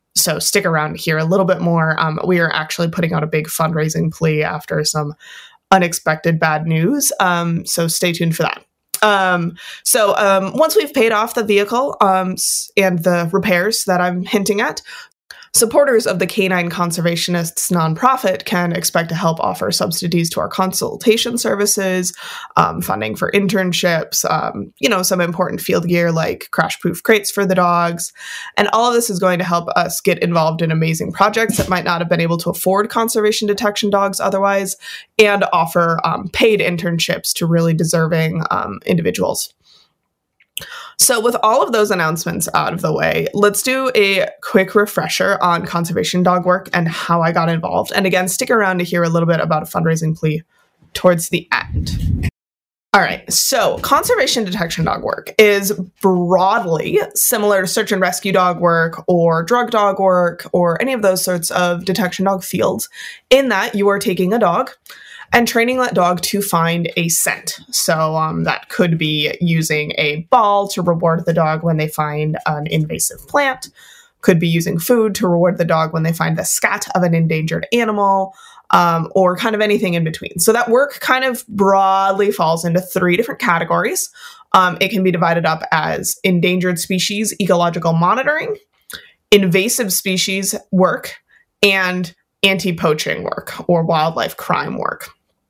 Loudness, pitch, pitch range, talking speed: -16 LUFS, 185 Hz, 170-205 Hz, 175 wpm